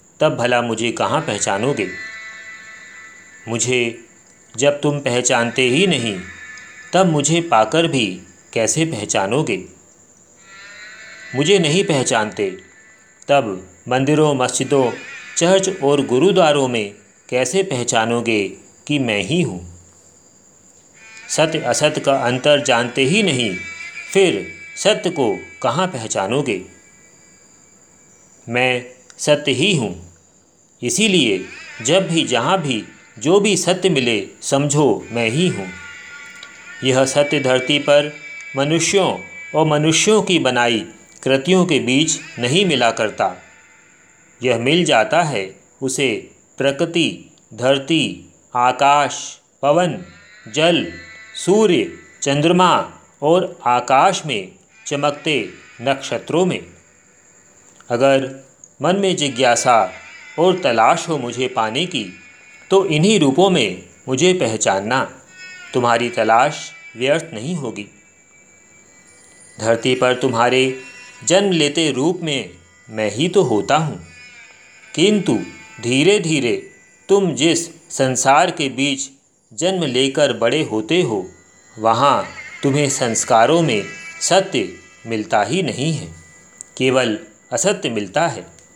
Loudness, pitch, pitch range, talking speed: -17 LUFS, 140 Hz, 120-175 Hz, 105 wpm